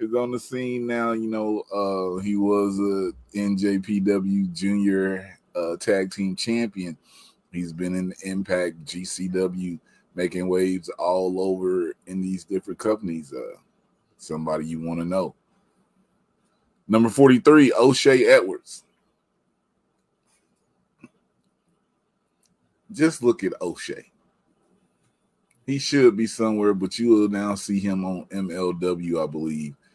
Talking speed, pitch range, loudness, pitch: 115 wpm, 90-115 Hz, -23 LUFS, 100 Hz